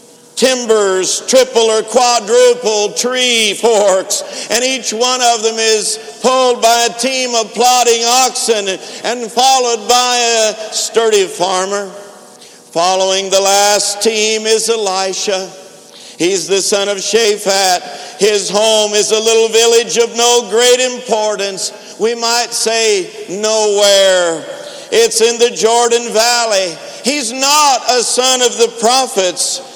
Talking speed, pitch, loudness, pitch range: 125 wpm, 225 Hz, -12 LUFS, 205-245 Hz